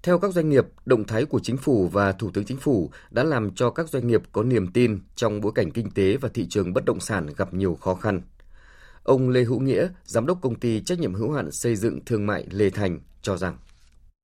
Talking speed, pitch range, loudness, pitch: 245 wpm, 95-125 Hz, -24 LUFS, 110 Hz